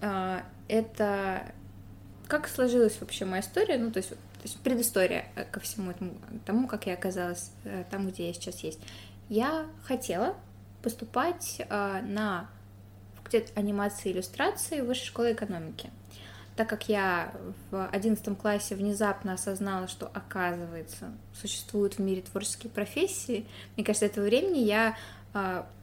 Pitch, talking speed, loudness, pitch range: 195 Hz, 130 wpm, -31 LUFS, 170-220 Hz